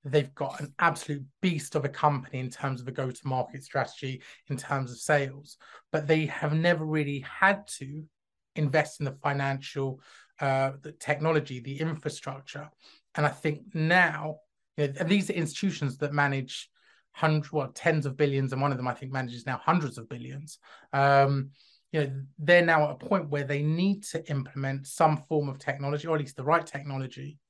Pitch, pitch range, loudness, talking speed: 145 Hz, 135-155 Hz, -28 LUFS, 185 wpm